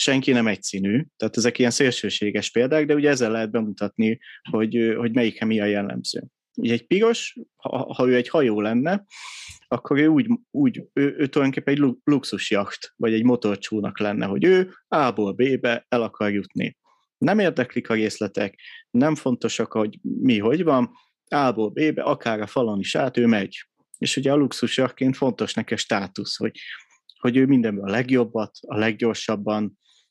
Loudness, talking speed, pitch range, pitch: -22 LUFS, 165 wpm, 110-140 Hz, 120 Hz